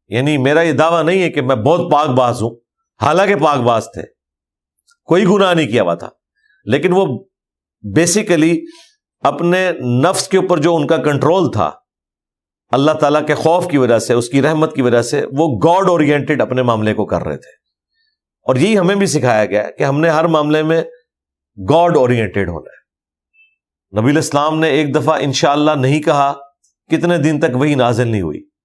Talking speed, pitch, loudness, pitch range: 180 wpm, 150 Hz, -14 LUFS, 125-170 Hz